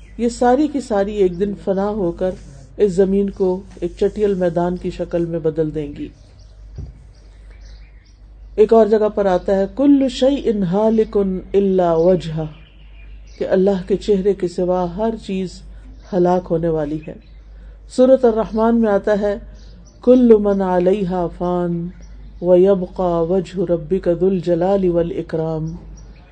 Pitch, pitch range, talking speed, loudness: 185 Hz, 175-205 Hz, 135 wpm, -17 LUFS